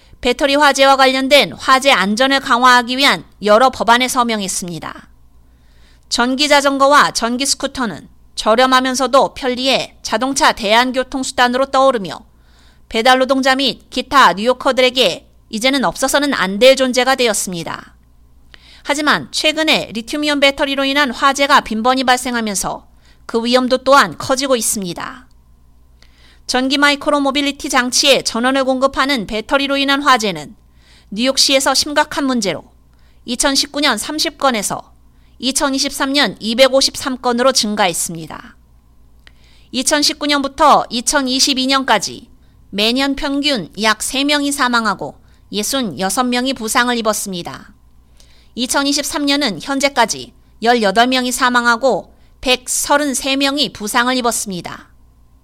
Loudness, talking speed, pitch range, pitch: -14 LUFS, 260 characters per minute, 210-275 Hz, 255 Hz